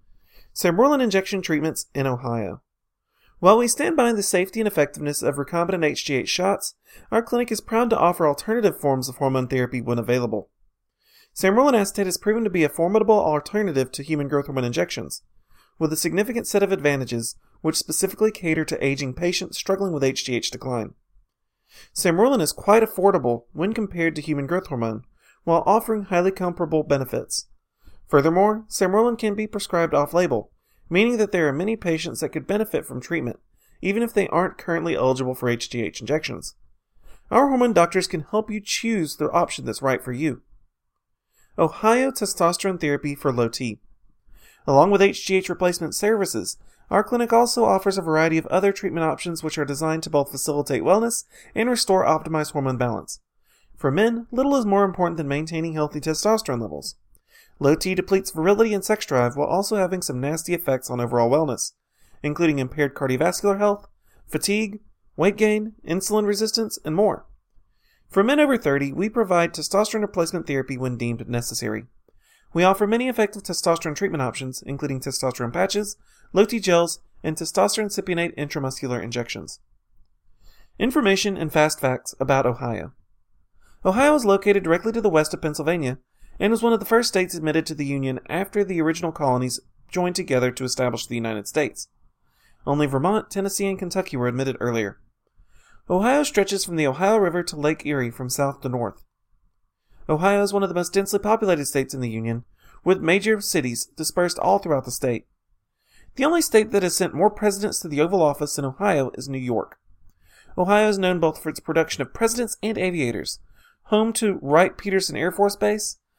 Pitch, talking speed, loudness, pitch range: 170 Hz, 170 wpm, -22 LUFS, 135-200 Hz